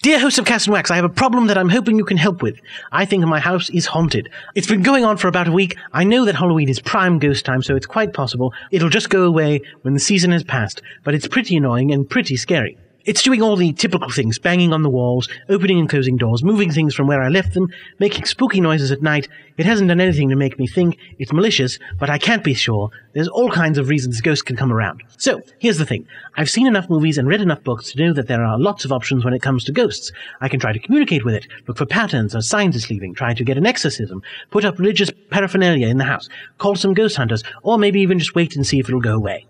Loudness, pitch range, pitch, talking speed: -17 LUFS, 130-195 Hz, 155 Hz, 265 wpm